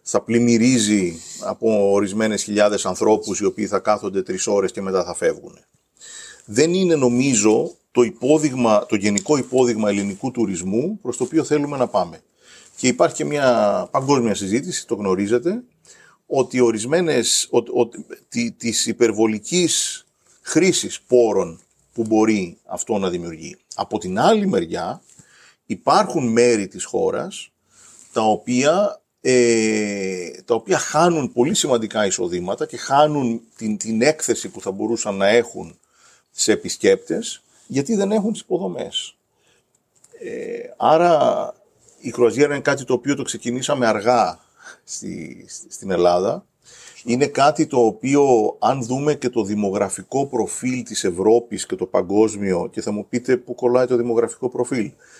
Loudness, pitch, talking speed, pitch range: -19 LUFS, 120 Hz, 135 wpm, 110-145 Hz